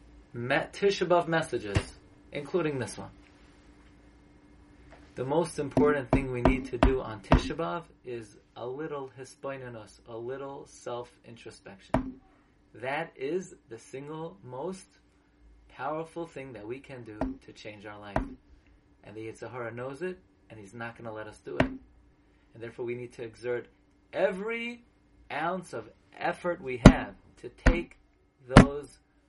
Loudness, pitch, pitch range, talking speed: -30 LUFS, 120 Hz, 105-150 Hz, 135 wpm